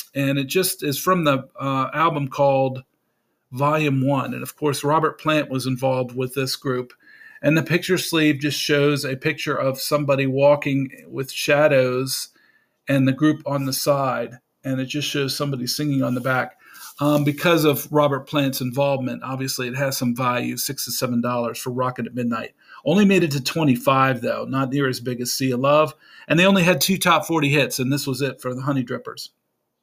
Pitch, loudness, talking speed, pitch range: 140 Hz, -21 LUFS, 195 wpm, 130-150 Hz